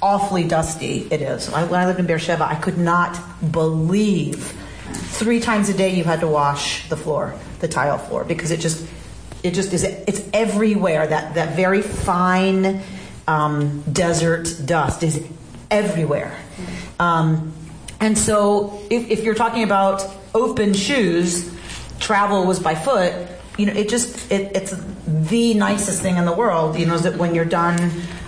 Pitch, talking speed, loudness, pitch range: 175 Hz, 165 wpm, -19 LUFS, 160-200 Hz